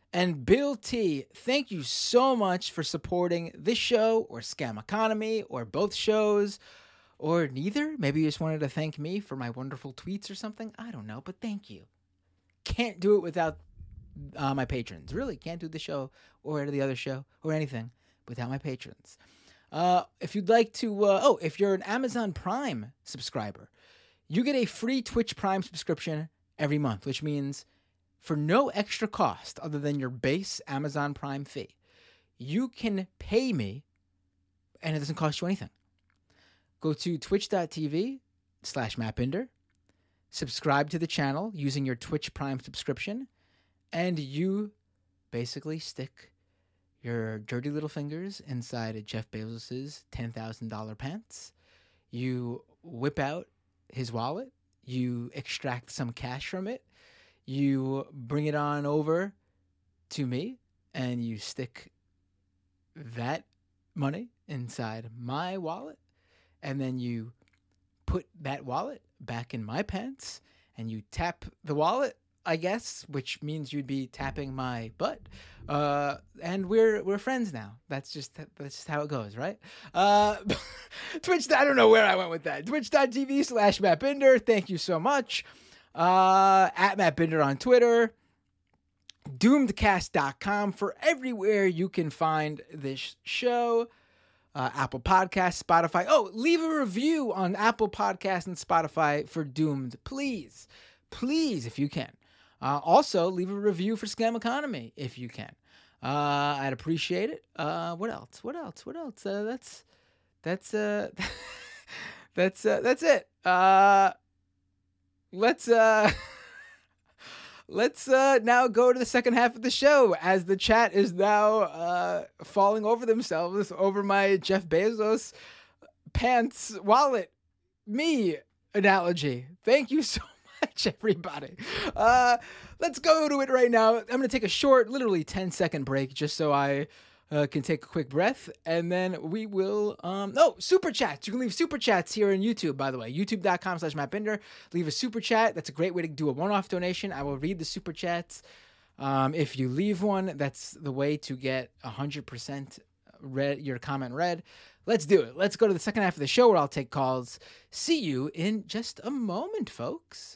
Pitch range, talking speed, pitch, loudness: 130-210 Hz, 155 wpm, 160 Hz, -28 LUFS